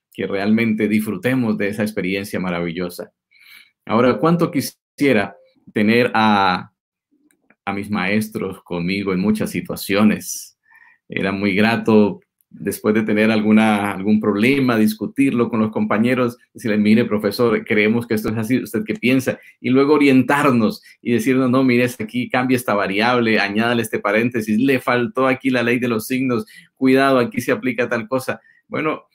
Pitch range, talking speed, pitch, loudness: 105-130 Hz, 150 wpm, 115 Hz, -18 LUFS